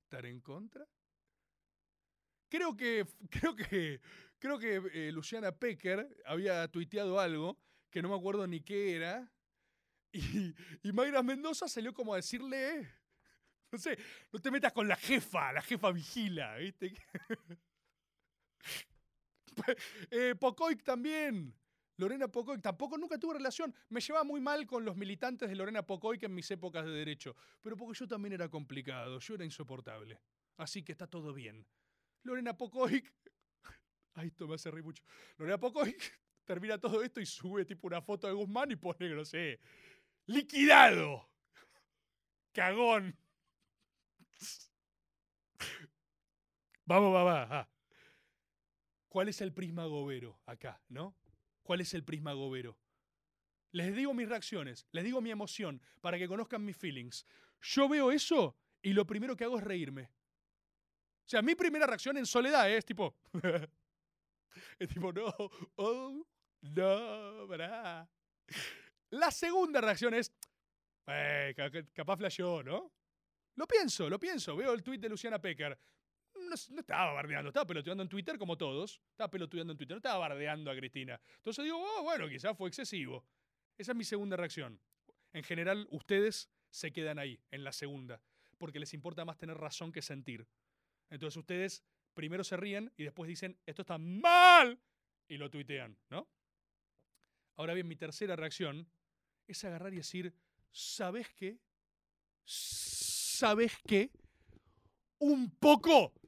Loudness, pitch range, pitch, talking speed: -35 LUFS, 155-235 Hz, 190 Hz, 145 wpm